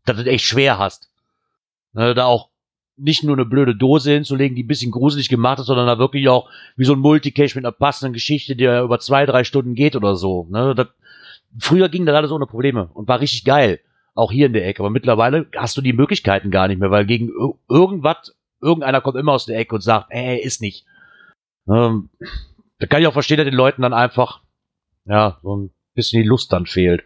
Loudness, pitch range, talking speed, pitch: -17 LUFS, 115-140 Hz, 215 wpm, 125 Hz